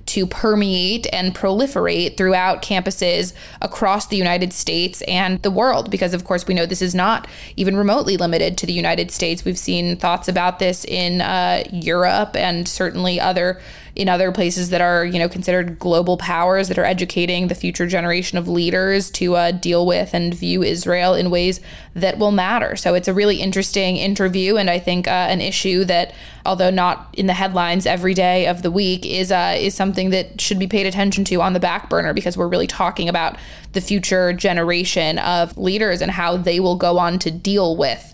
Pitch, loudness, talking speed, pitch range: 185 Hz, -18 LUFS, 195 wpm, 175-190 Hz